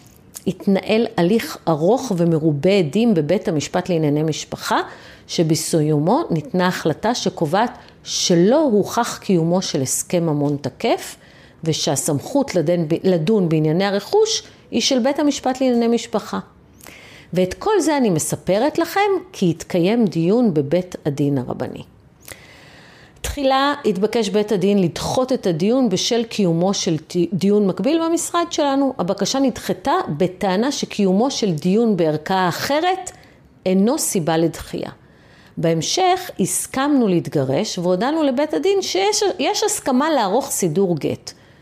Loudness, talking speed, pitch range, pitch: -19 LUFS, 115 wpm, 165-260 Hz, 195 Hz